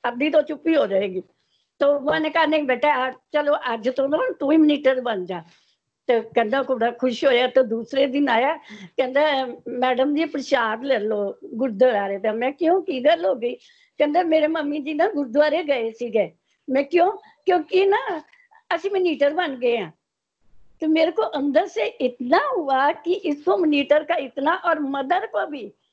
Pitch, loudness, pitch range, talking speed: 285 Hz, -21 LUFS, 255-320 Hz, 185 wpm